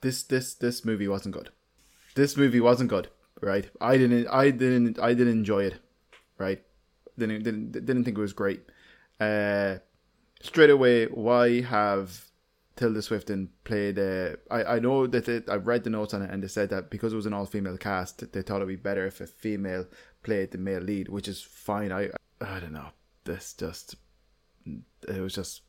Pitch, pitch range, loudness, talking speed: 105 Hz, 95-120 Hz, -27 LUFS, 195 wpm